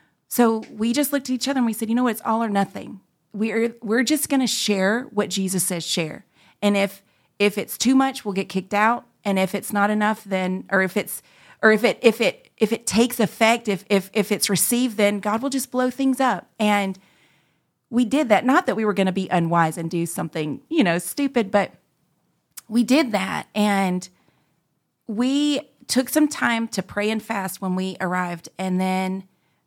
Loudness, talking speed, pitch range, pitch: -22 LUFS, 210 wpm, 190-240 Hz, 210 Hz